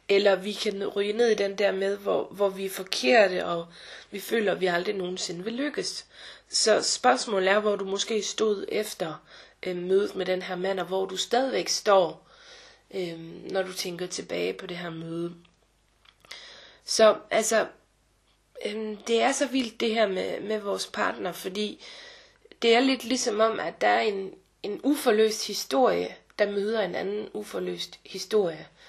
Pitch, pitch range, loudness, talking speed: 205 Hz, 190-225 Hz, -26 LUFS, 170 wpm